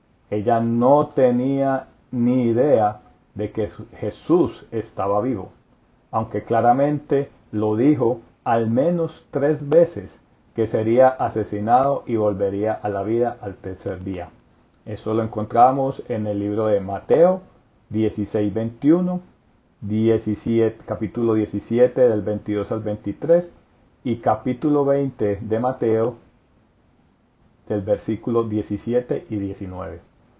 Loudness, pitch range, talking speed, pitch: -21 LUFS, 105-125 Hz, 110 wpm, 110 Hz